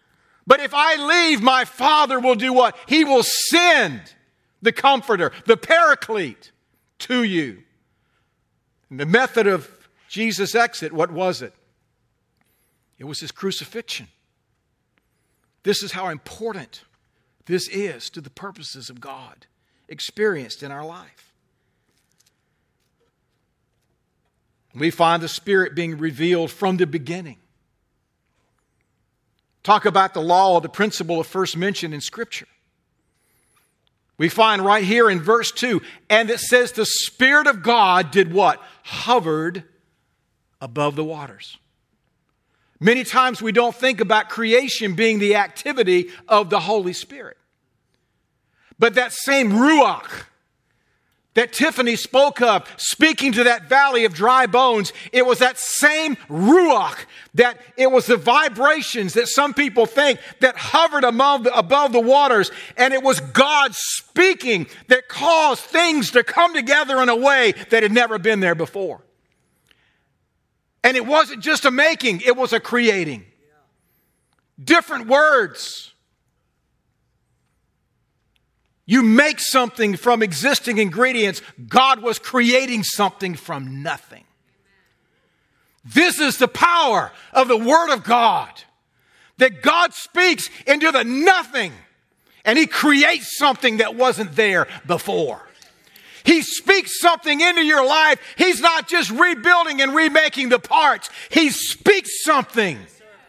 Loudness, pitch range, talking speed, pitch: -17 LUFS, 190-280 Hz, 125 wpm, 240 Hz